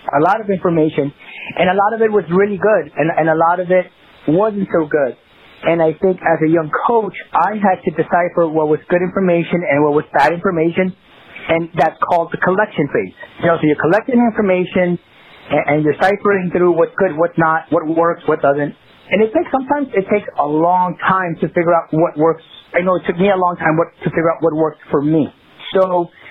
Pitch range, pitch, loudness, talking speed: 160-190 Hz, 175 Hz, -15 LUFS, 220 wpm